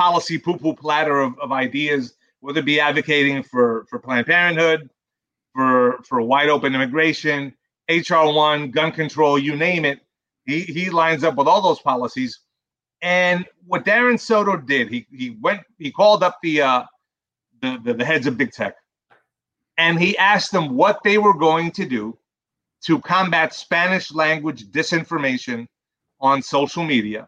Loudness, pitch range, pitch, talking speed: -18 LUFS, 140-175 Hz, 160 Hz, 155 wpm